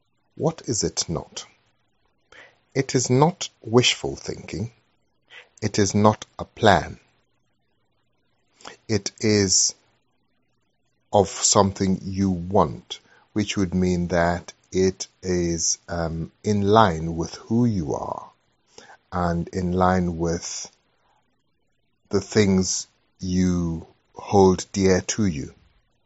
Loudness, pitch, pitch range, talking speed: -22 LUFS, 95 Hz, 90-105 Hz, 100 wpm